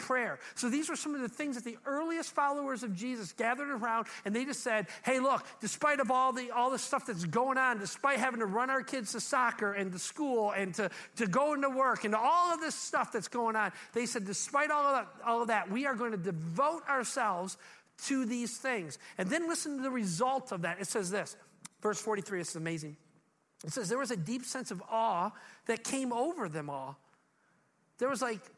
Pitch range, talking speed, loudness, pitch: 205-265 Hz, 225 wpm, -33 LUFS, 235 Hz